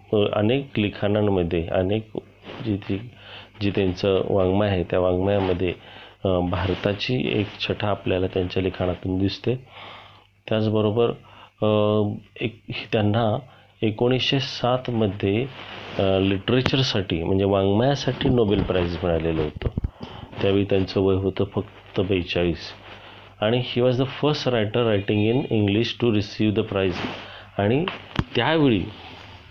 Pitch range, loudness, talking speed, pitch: 95-115 Hz, -23 LUFS, 105 wpm, 100 Hz